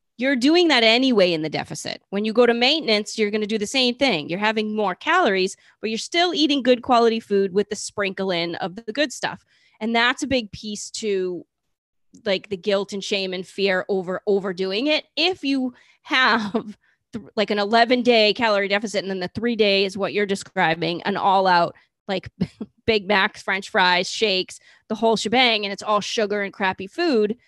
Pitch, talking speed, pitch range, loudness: 210 Hz, 200 wpm, 190-230 Hz, -21 LUFS